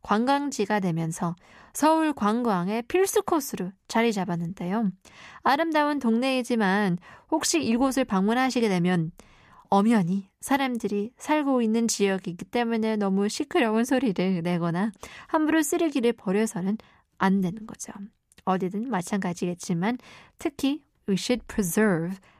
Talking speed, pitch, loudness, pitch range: 320 characters per minute, 220 Hz, -26 LUFS, 190-255 Hz